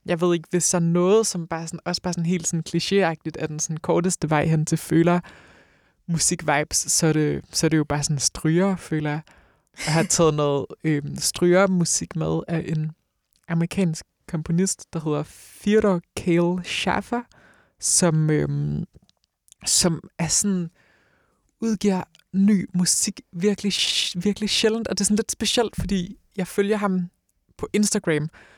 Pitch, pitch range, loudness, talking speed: 175 Hz, 160-195 Hz, -22 LUFS, 160 wpm